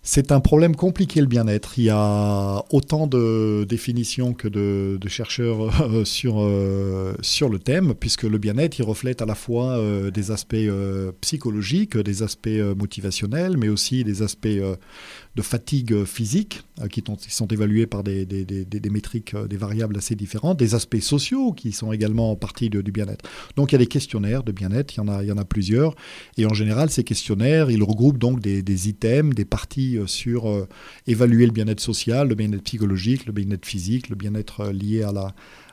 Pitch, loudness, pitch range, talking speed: 110 Hz, -22 LUFS, 105-120 Hz, 195 wpm